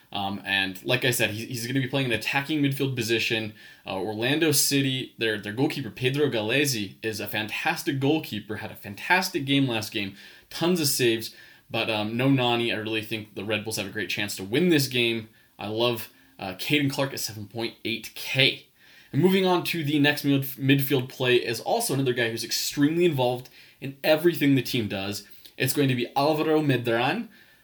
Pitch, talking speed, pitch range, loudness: 125 Hz, 190 wpm, 110-145 Hz, -25 LUFS